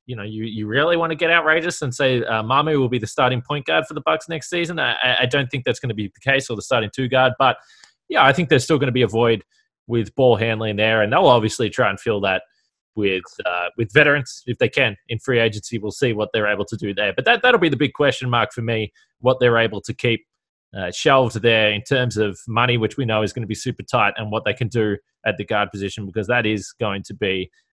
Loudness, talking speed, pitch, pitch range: -19 LUFS, 270 wpm, 120 Hz, 110-135 Hz